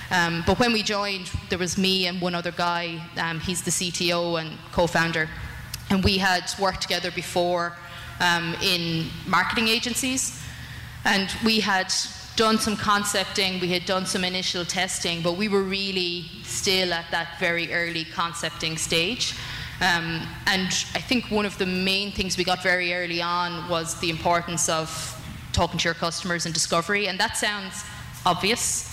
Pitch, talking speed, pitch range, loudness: 180 Hz, 165 wpm, 170-195 Hz, -24 LUFS